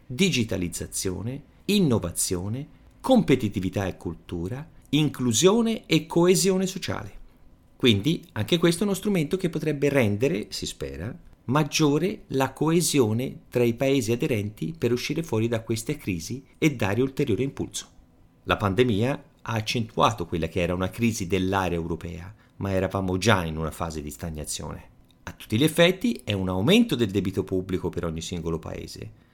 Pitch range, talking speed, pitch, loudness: 95-150 Hz, 145 wpm, 115 Hz, -25 LUFS